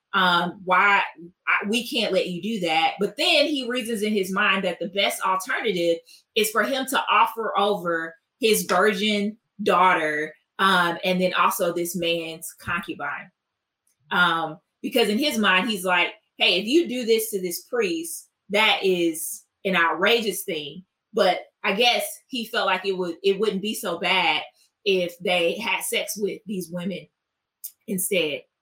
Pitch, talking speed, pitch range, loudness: 195 Hz, 160 wpm, 175-220 Hz, -22 LUFS